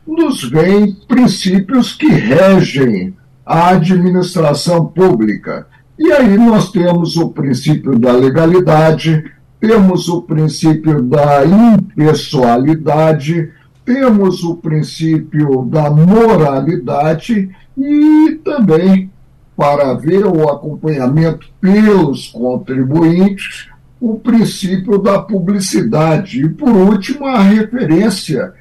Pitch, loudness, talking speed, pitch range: 175 Hz, -11 LUFS, 90 wpm, 155-205 Hz